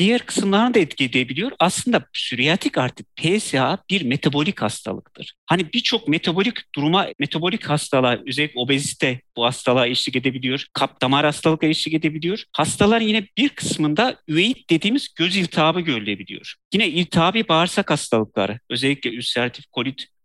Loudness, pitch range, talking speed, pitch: -20 LUFS, 130-195 Hz, 135 wpm, 155 Hz